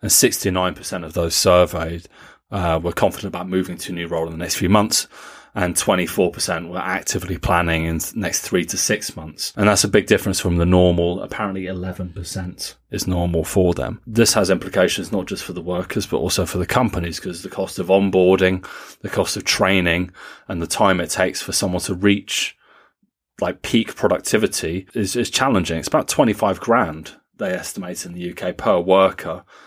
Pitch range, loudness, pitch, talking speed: 85-95 Hz, -19 LUFS, 90 Hz, 190 wpm